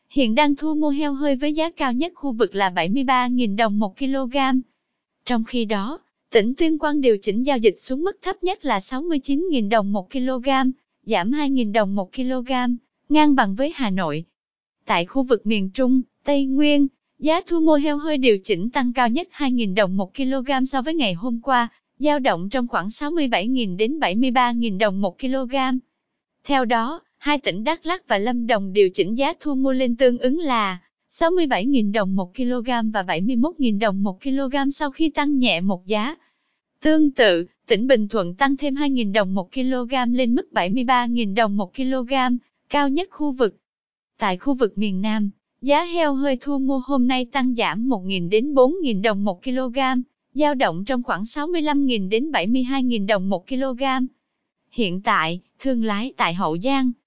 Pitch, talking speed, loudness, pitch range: 255 Hz, 180 wpm, -21 LUFS, 220-280 Hz